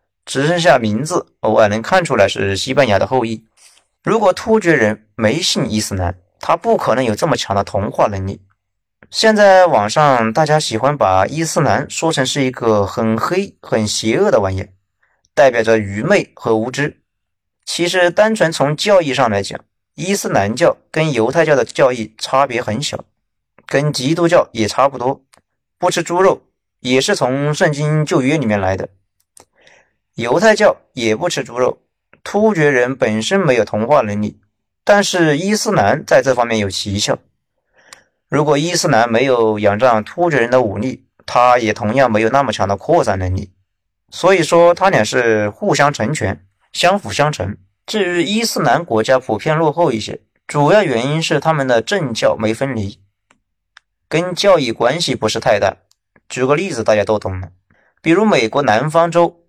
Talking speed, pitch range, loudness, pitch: 250 characters per minute, 105-165 Hz, -15 LUFS, 125 Hz